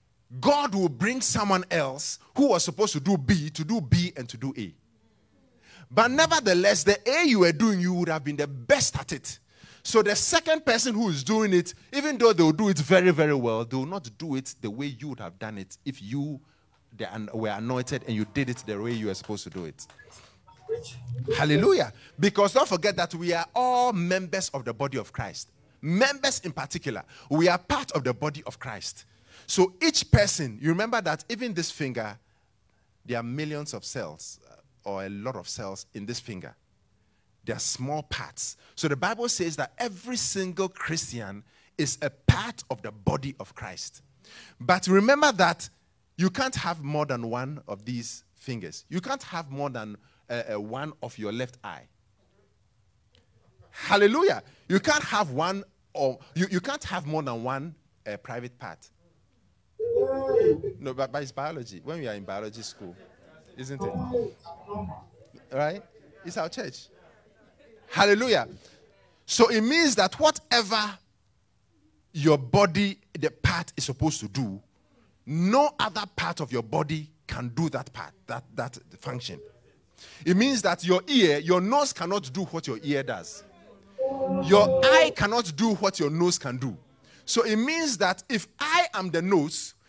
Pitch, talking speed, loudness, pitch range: 150 Hz, 175 wpm, -26 LUFS, 120-200 Hz